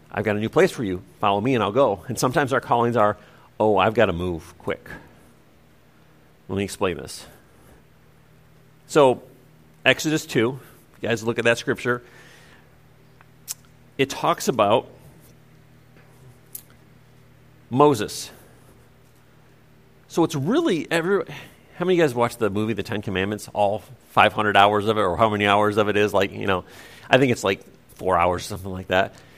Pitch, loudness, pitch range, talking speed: 120 Hz, -22 LUFS, 105-135 Hz, 165 wpm